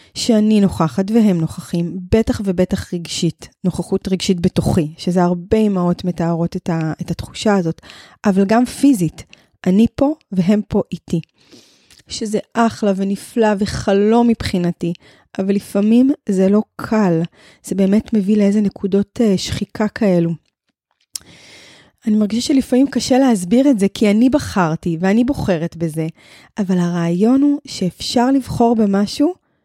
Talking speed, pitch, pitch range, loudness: 125 wpm, 200 Hz, 175-225 Hz, -17 LUFS